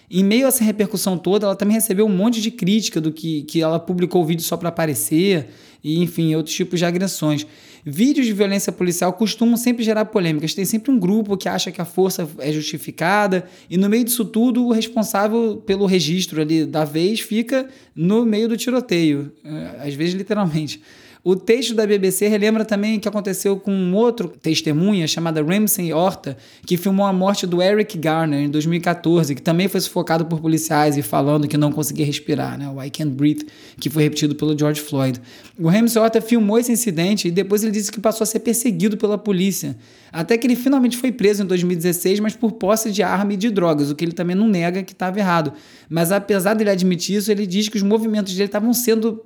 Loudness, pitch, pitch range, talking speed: -19 LUFS, 190 Hz, 160-215 Hz, 210 wpm